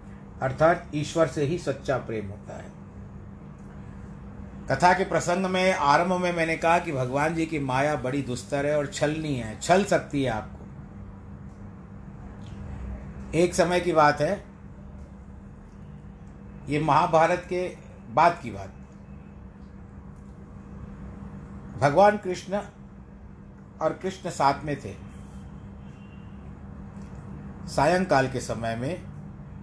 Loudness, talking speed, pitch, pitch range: -25 LUFS, 105 wpm, 135 Hz, 95-165 Hz